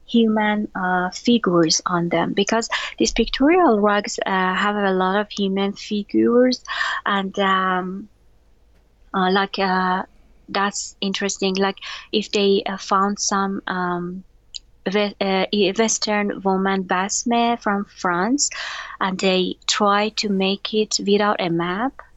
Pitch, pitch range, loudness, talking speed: 200 Hz, 190-215 Hz, -20 LUFS, 120 wpm